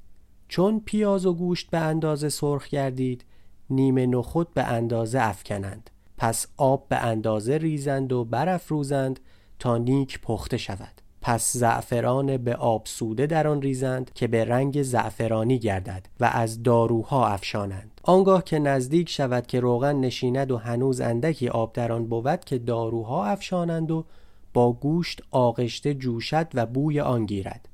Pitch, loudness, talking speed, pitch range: 125 Hz, -25 LUFS, 145 wpm, 115-145 Hz